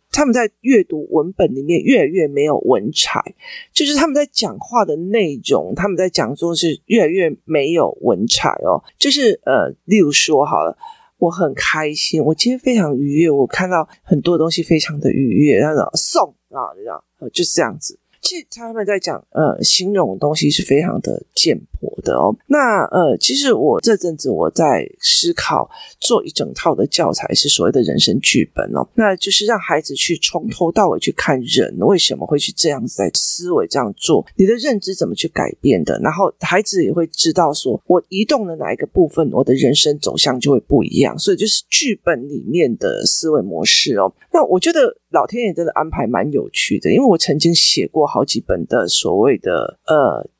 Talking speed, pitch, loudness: 285 characters per minute, 195 Hz, -15 LUFS